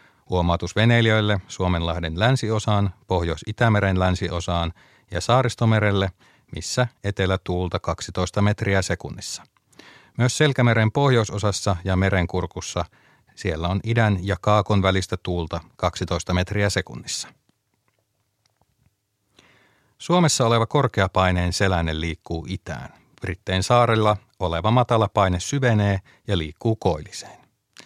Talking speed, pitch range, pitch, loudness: 95 wpm, 90-115 Hz, 100 Hz, -22 LUFS